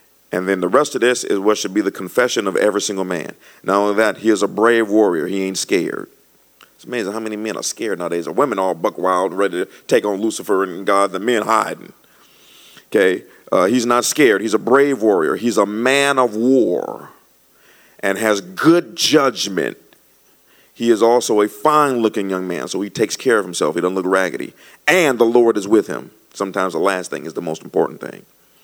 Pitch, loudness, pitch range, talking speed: 105 Hz, -17 LUFS, 95-120 Hz, 210 wpm